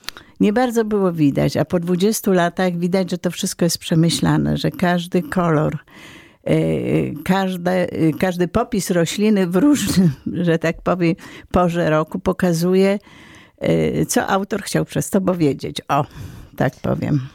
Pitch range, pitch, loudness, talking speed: 160-195 Hz, 180 Hz, -19 LUFS, 140 wpm